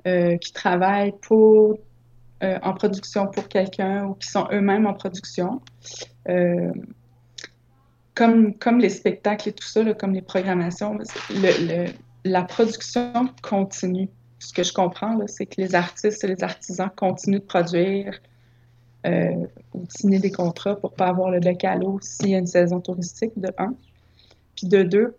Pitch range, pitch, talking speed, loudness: 175-200 Hz, 190 Hz, 170 wpm, -22 LUFS